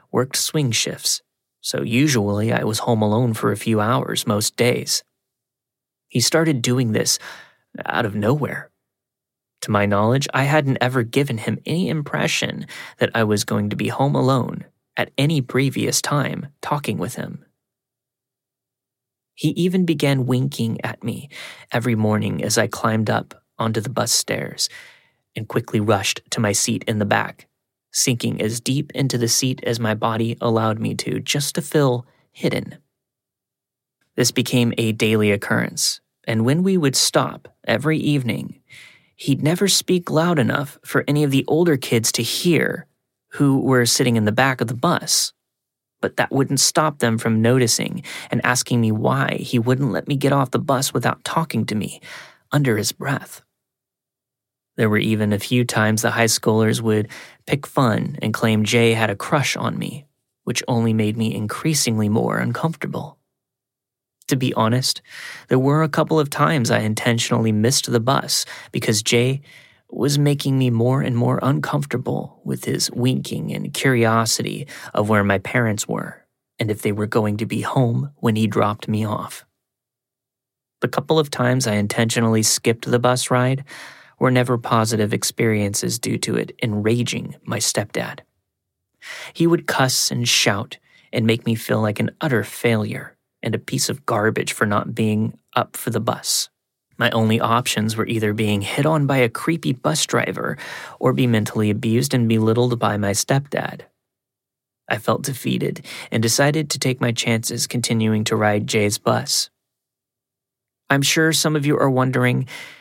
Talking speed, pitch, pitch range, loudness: 165 wpm, 125 Hz, 110-135 Hz, -20 LUFS